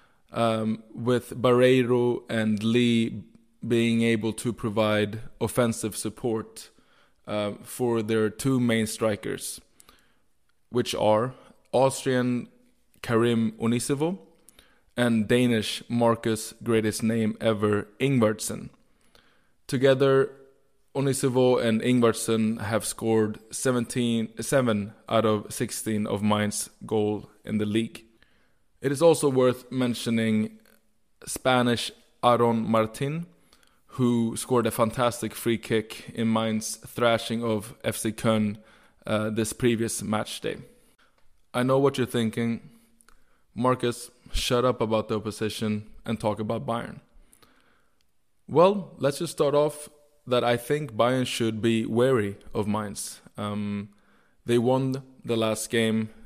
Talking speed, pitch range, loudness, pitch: 115 wpm, 110-125 Hz, -26 LUFS, 115 Hz